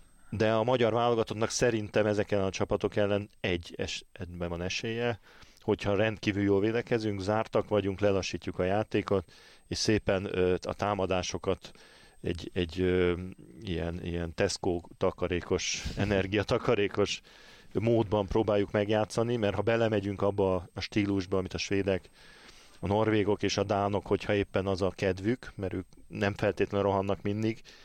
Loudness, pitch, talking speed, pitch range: -30 LUFS, 100 Hz, 130 wpm, 95-105 Hz